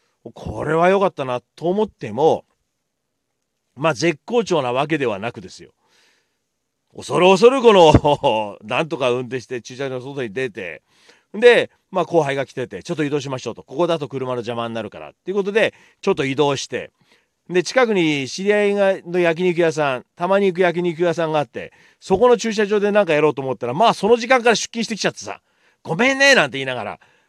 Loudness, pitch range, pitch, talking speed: -18 LUFS, 135-210 Hz, 170 Hz, 380 characters per minute